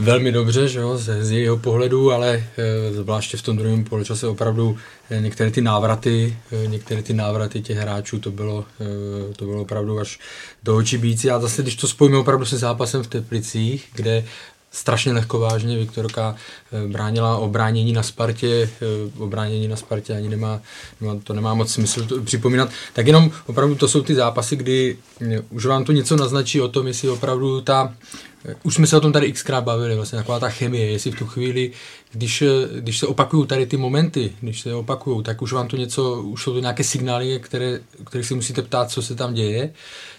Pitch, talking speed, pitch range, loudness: 120 Hz, 190 wpm, 110-130 Hz, -20 LUFS